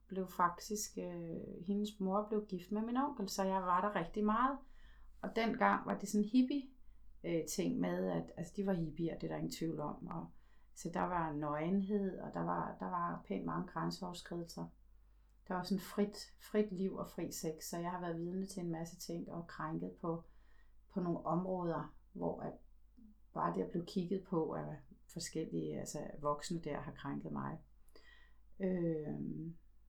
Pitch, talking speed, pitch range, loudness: 180 Hz, 175 wpm, 160-205 Hz, -40 LUFS